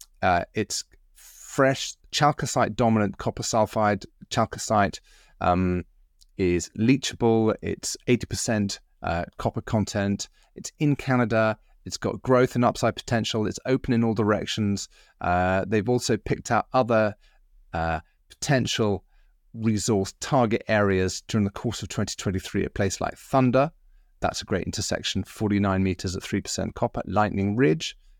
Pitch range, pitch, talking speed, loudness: 95-120 Hz, 110 Hz, 130 wpm, -25 LUFS